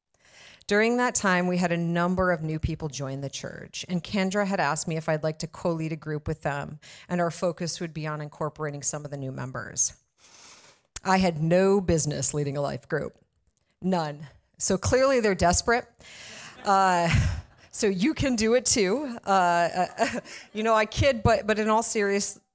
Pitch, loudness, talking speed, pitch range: 175 Hz, -26 LUFS, 185 wpm, 155-200 Hz